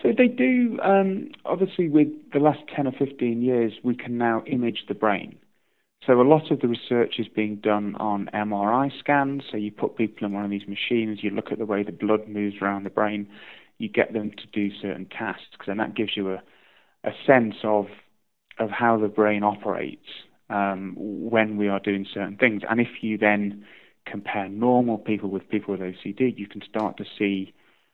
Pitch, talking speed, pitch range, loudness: 110 Hz, 200 wpm, 100-125 Hz, -24 LUFS